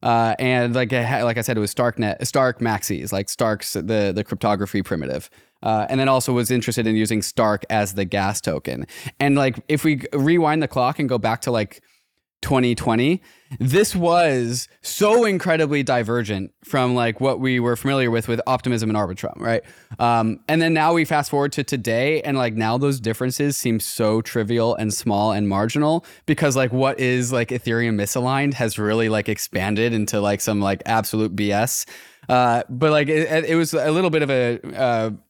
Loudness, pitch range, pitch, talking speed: -20 LUFS, 110-140 Hz, 120 Hz, 185 wpm